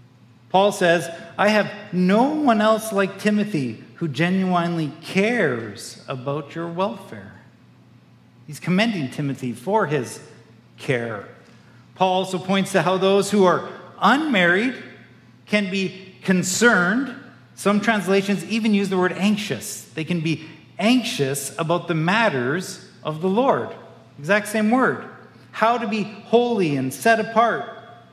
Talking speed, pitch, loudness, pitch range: 130 wpm, 185 Hz, -21 LUFS, 150-210 Hz